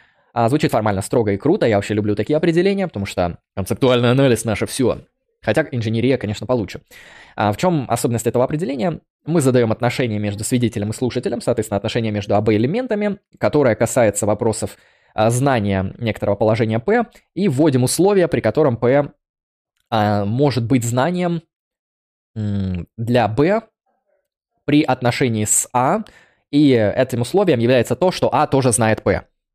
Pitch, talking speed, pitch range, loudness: 120 Hz, 140 wpm, 110-150 Hz, -18 LUFS